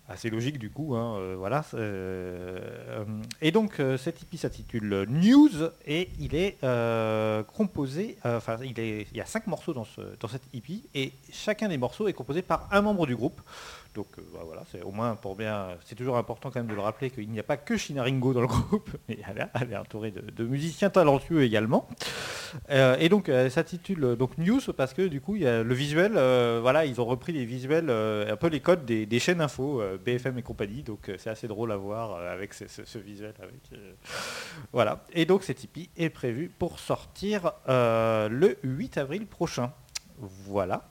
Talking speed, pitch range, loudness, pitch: 210 wpm, 110-165 Hz, -28 LUFS, 130 Hz